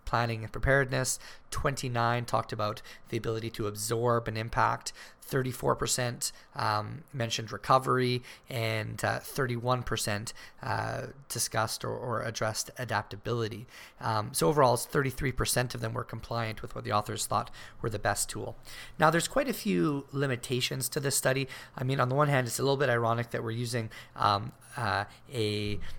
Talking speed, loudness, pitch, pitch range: 165 wpm, -31 LUFS, 120 Hz, 110-130 Hz